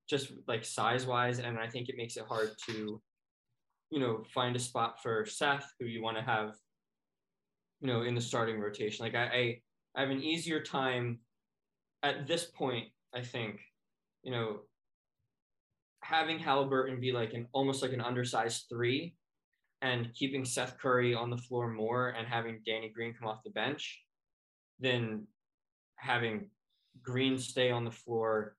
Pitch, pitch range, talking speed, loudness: 120 Hz, 115-130 Hz, 160 wpm, -35 LUFS